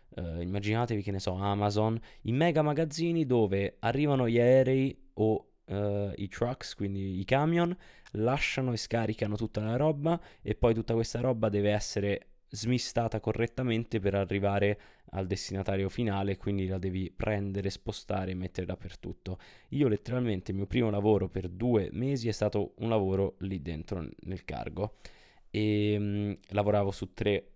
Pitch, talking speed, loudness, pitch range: 105 Hz, 150 wpm, -31 LUFS, 100-120 Hz